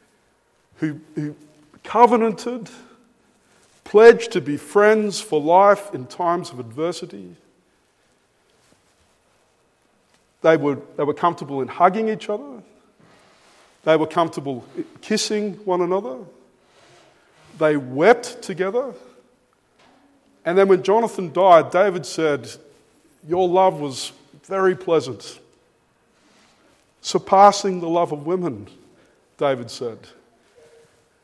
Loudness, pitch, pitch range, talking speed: -19 LUFS, 180 Hz, 155-210 Hz, 95 wpm